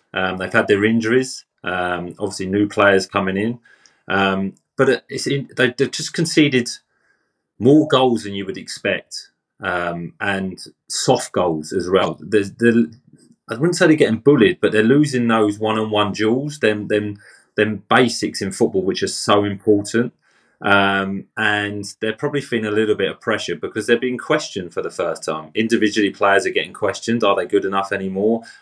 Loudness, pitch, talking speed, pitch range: -19 LUFS, 105 Hz, 165 wpm, 100-120 Hz